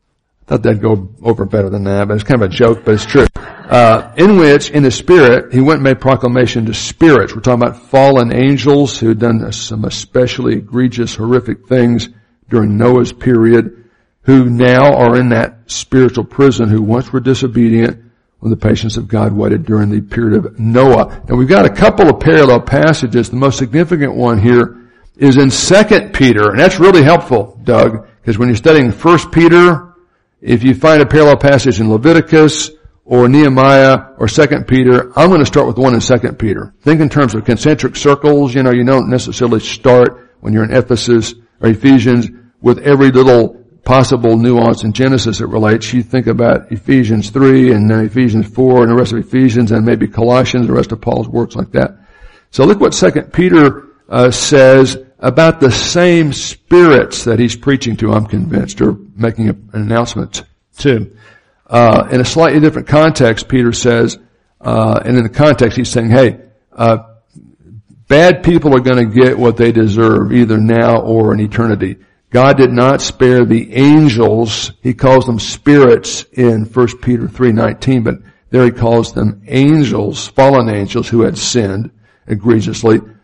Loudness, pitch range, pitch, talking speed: -10 LUFS, 115-135 Hz, 120 Hz, 180 wpm